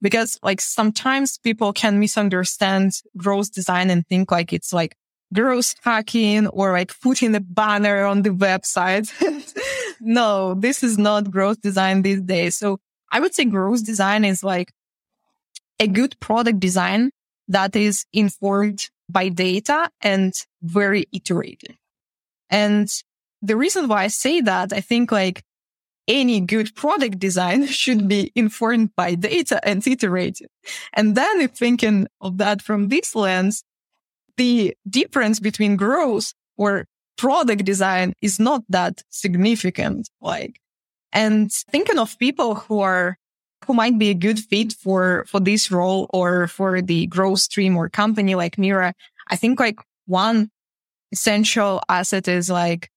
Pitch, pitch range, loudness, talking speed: 205 Hz, 190-225 Hz, -19 LUFS, 145 wpm